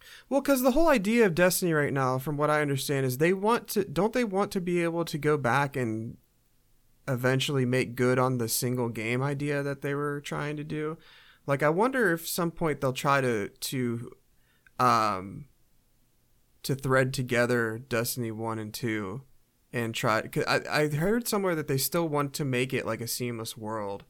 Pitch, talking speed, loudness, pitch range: 135 Hz, 190 wpm, -28 LUFS, 120-160 Hz